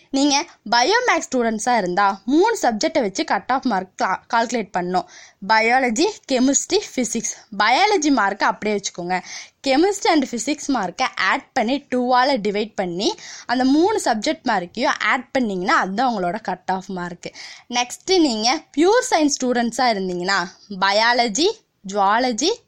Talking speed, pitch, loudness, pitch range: 125 wpm, 250 Hz, -19 LUFS, 205-295 Hz